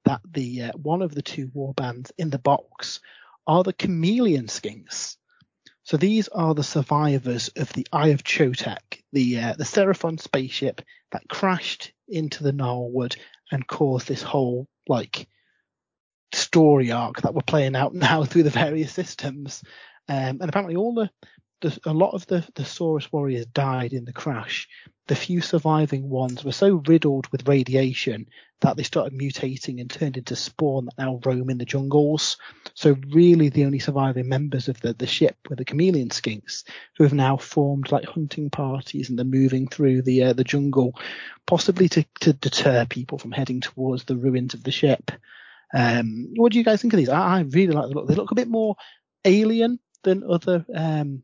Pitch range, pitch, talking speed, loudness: 130-165 Hz, 140 Hz, 180 wpm, -23 LUFS